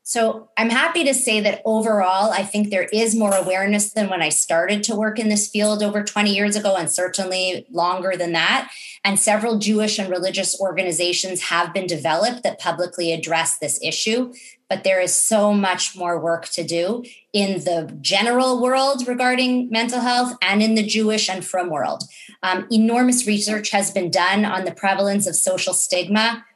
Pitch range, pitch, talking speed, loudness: 180-220 Hz, 200 Hz, 180 wpm, -19 LUFS